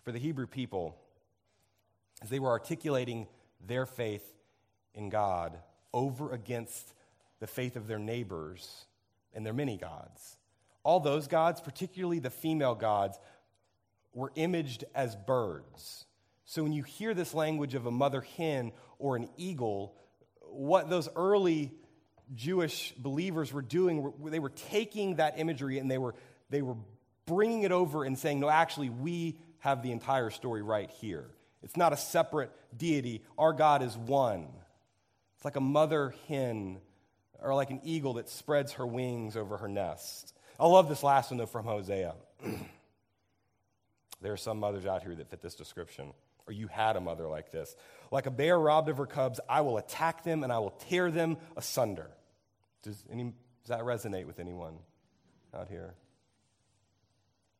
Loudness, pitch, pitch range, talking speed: -33 LUFS, 125 Hz, 105-150 Hz, 160 wpm